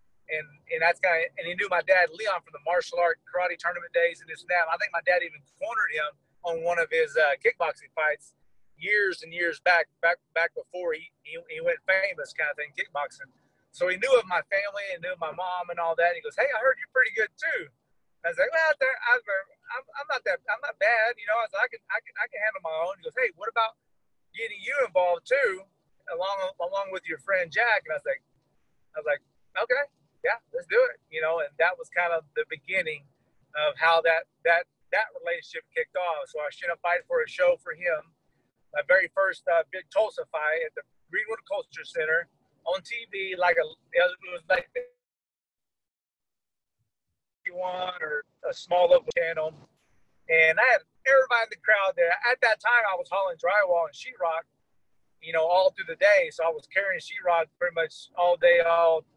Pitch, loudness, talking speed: 195 Hz, -26 LUFS, 215 wpm